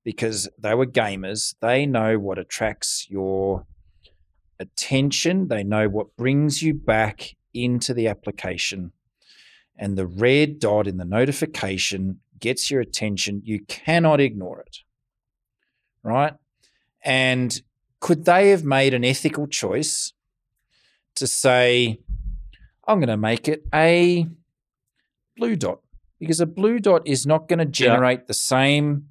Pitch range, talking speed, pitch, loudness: 105-145 Hz, 130 wpm, 125 Hz, -21 LUFS